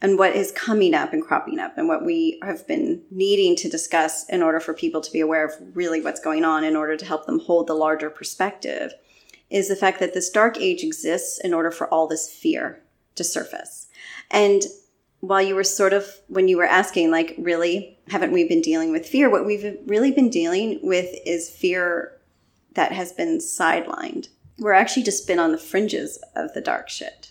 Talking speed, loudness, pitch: 205 wpm, -22 LUFS, 195 Hz